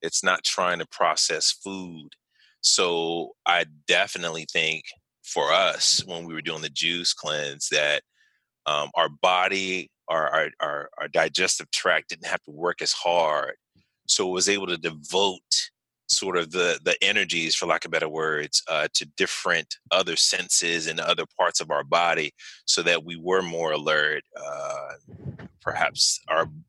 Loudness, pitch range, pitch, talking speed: -23 LUFS, 80-100 Hz, 85 Hz, 155 wpm